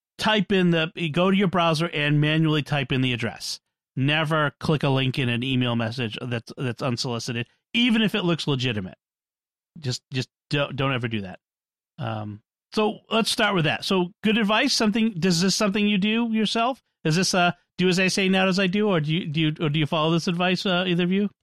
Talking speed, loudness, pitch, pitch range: 220 wpm, -23 LUFS, 165 Hz, 135-195 Hz